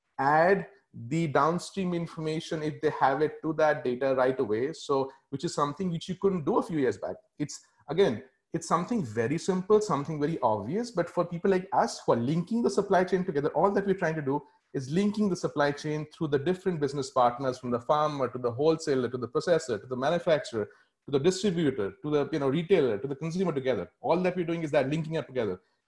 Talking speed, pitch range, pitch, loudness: 220 wpm, 145-180 Hz, 160 Hz, -28 LUFS